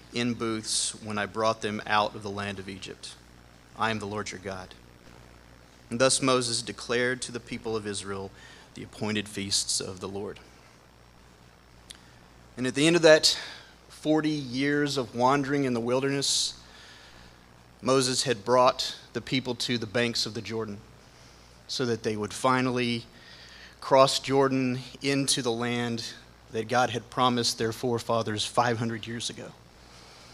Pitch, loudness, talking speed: 115 Hz, -27 LUFS, 150 wpm